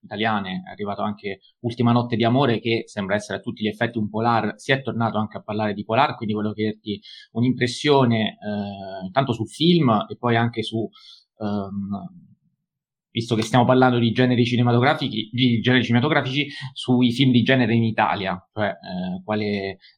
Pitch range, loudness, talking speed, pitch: 105-125 Hz, -22 LUFS, 160 wpm, 115 Hz